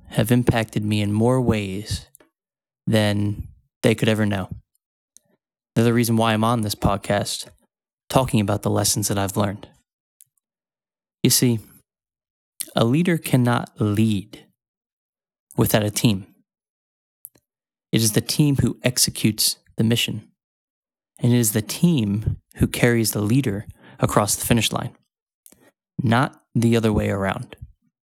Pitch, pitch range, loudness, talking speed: 110 Hz, 105-120 Hz, -21 LUFS, 130 wpm